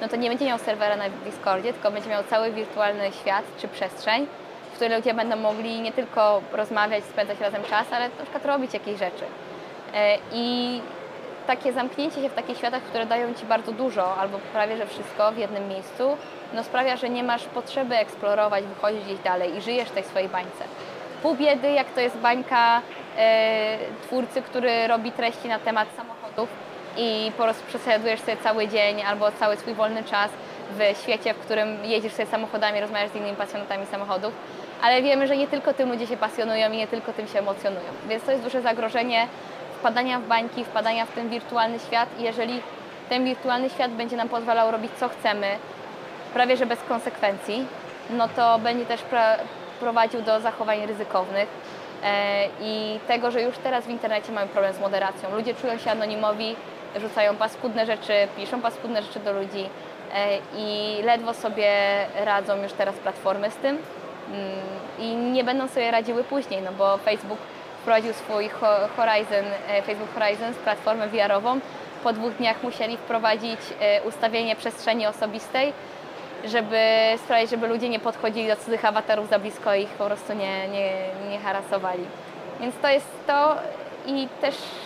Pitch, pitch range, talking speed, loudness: 225 Hz, 205-240 Hz, 170 wpm, -25 LUFS